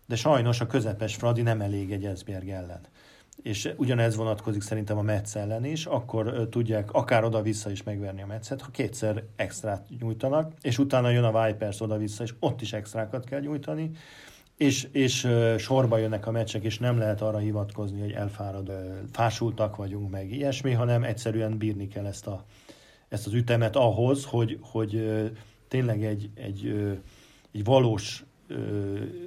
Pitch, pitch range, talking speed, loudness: 110 Hz, 105-120 Hz, 155 wpm, -28 LUFS